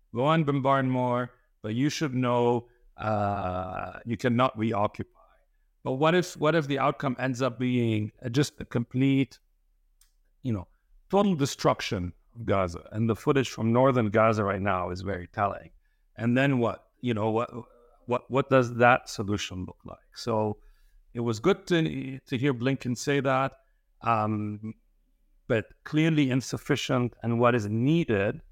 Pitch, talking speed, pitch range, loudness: 120 Hz, 155 wpm, 105-135 Hz, -27 LUFS